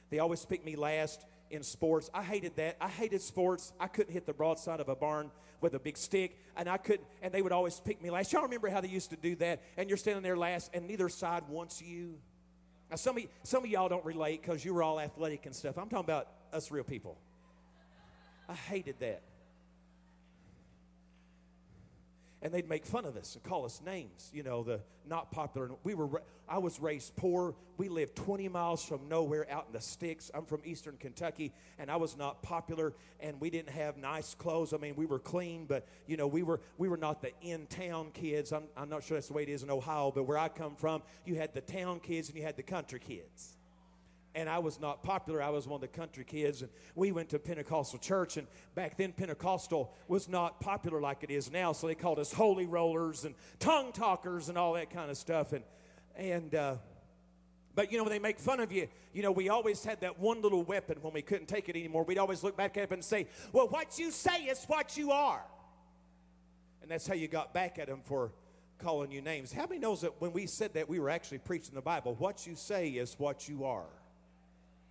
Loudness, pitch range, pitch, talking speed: -37 LUFS, 145-180 Hz, 160 Hz, 230 wpm